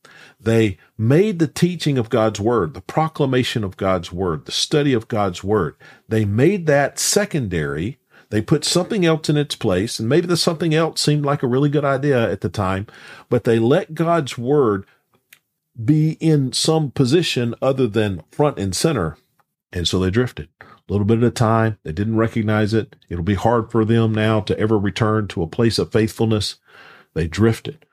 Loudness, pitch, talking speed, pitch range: -19 LUFS, 115 Hz, 185 wpm, 105-145 Hz